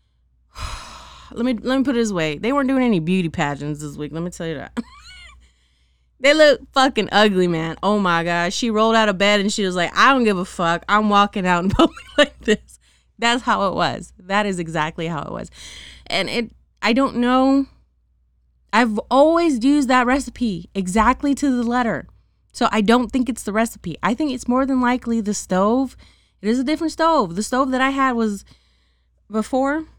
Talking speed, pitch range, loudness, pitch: 200 wpm, 175-260 Hz, -19 LUFS, 220 Hz